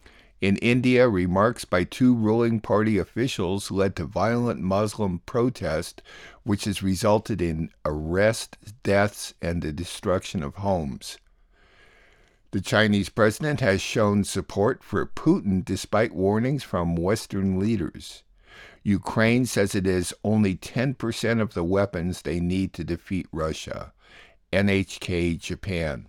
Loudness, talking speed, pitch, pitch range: -25 LUFS, 120 wpm, 100 Hz, 90-110 Hz